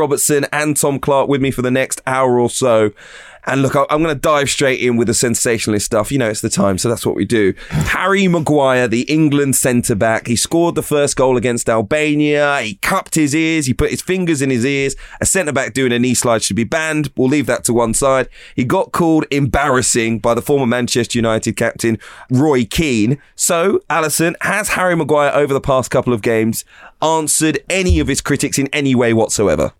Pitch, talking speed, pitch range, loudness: 135 Hz, 215 wpm, 120-150 Hz, -15 LUFS